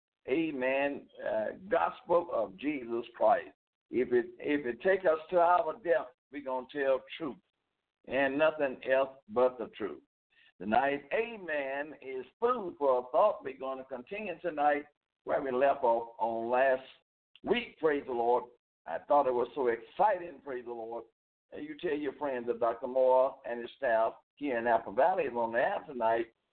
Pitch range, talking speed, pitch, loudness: 125-170 Hz, 175 wpm, 135 Hz, -32 LUFS